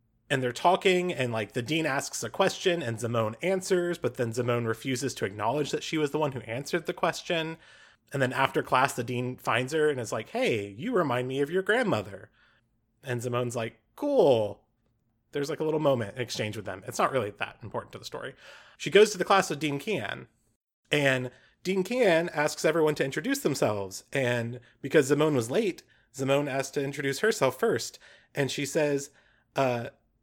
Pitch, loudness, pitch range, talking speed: 140 Hz, -28 LUFS, 120-160 Hz, 195 wpm